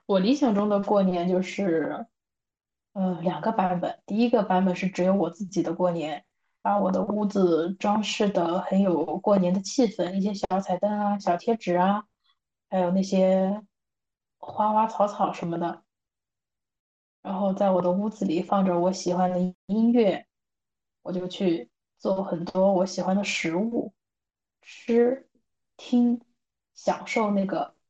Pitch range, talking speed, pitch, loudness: 180-210 Hz, 215 characters per minute, 190 Hz, -25 LUFS